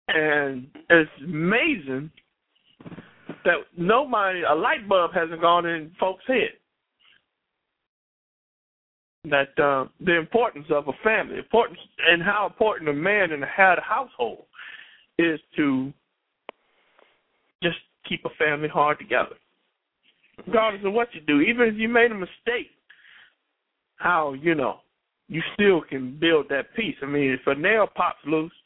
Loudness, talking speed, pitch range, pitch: -23 LUFS, 135 wpm, 150-220 Hz, 170 Hz